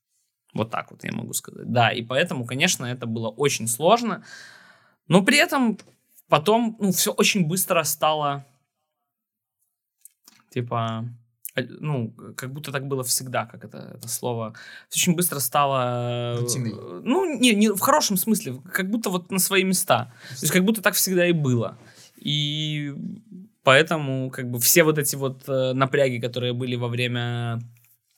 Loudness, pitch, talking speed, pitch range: -22 LUFS, 140 Hz, 150 wpm, 120-185 Hz